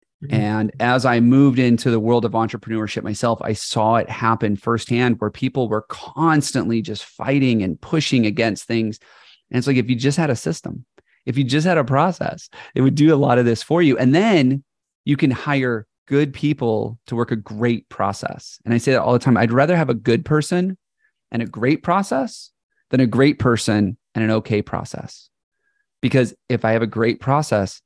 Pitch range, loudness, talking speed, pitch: 115-140 Hz, -19 LUFS, 200 wpm, 120 Hz